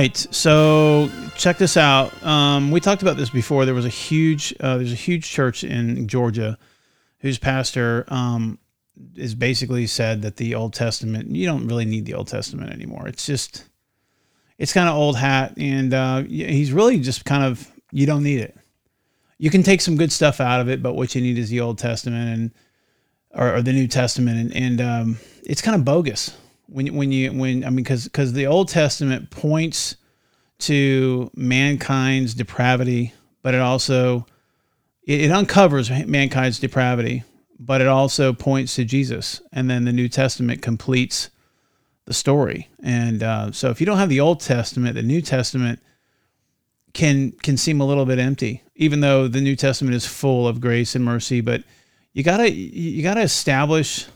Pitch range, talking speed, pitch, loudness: 120-145 Hz, 180 wpm, 130 Hz, -19 LUFS